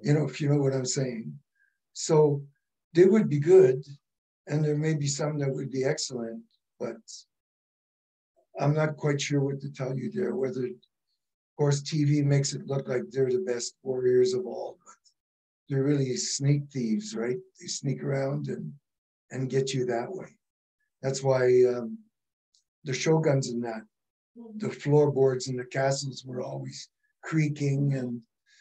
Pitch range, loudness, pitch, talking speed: 125-150 Hz, -27 LUFS, 135 Hz, 160 wpm